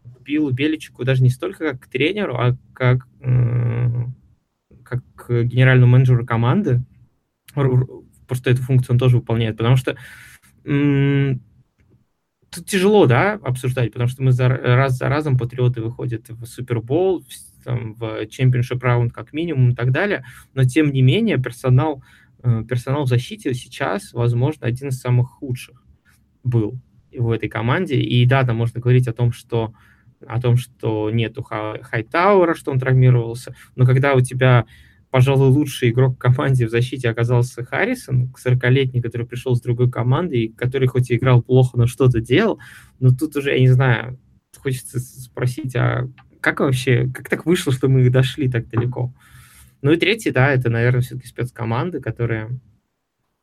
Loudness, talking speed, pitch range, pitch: -19 LUFS, 150 wpm, 120-130 Hz, 125 Hz